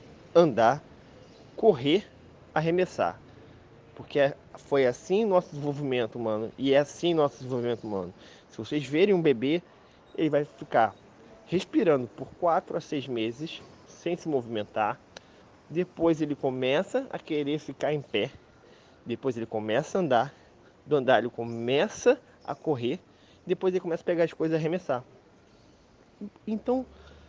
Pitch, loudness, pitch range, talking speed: 145 Hz, -28 LUFS, 120-170 Hz, 135 wpm